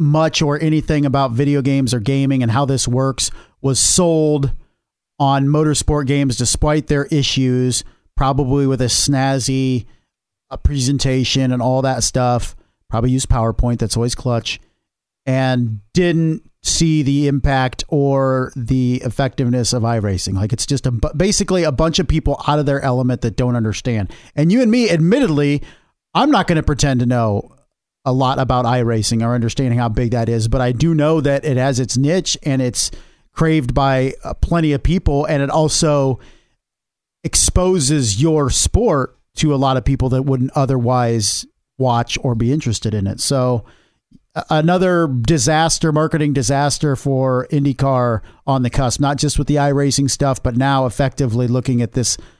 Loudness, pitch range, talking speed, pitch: -16 LUFS, 125-145 Hz, 160 wpm, 135 Hz